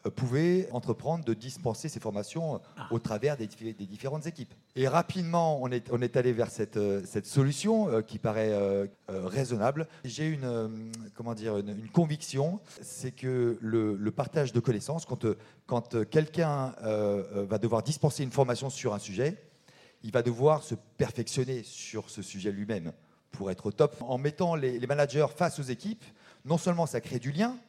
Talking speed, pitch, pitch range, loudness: 150 wpm, 125 Hz, 110-150 Hz, -31 LUFS